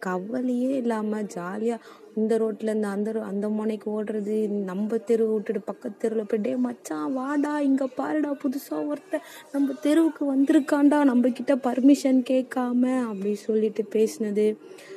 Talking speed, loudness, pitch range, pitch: 130 wpm, -25 LUFS, 215-275 Hz, 240 Hz